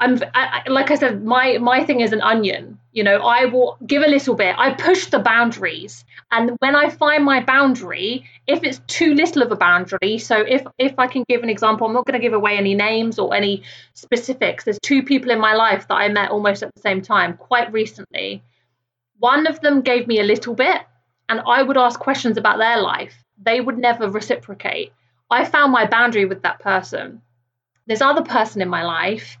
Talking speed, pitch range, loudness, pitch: 215 wpm, 205-260 Hz, -17 LUFS, 235 Hz